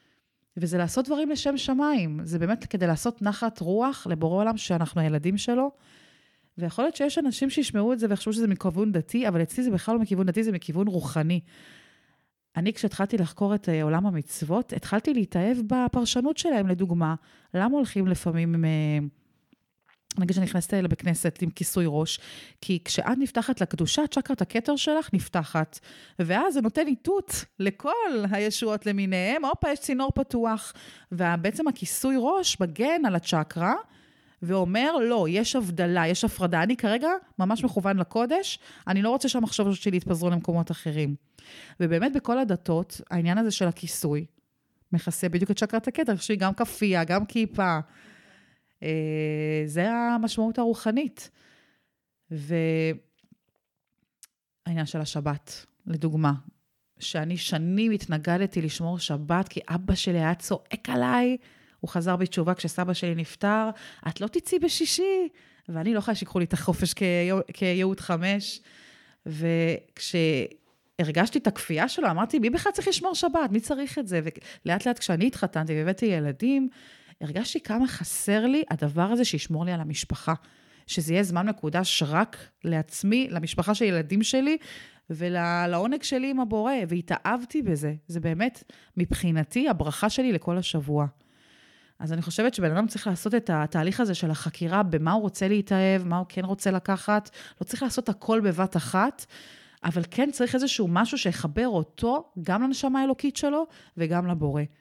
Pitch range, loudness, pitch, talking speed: 170-235 Hz, -26 LUFS, 190 Hz, 145 wpm